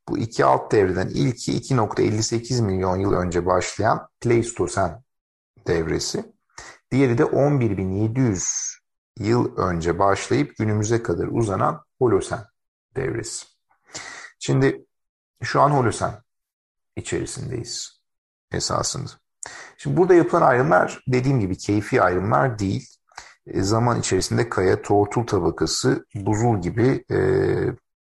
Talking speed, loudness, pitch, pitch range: 100 wpm, -22 LUFS, 110 Hz, 95-125 Hz